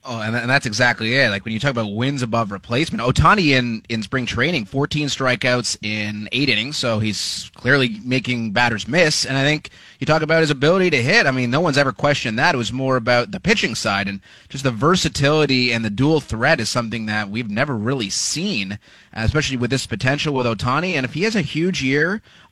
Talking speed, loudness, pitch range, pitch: 225 wpm, -19 LUFS, 115-145 Hz, 130 Hz